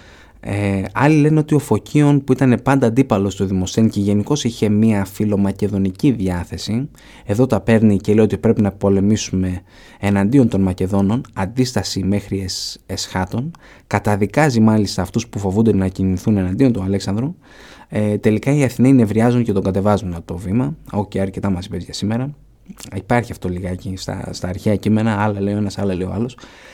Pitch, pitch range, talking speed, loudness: 105 Hz, 95-115 Hz, 170 wpm, -18 LUFS